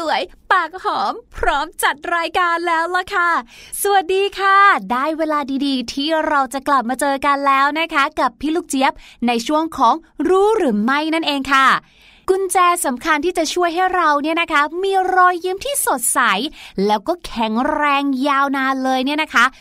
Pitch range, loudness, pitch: 275-360 Hz, -17 LUFS, 310 Hz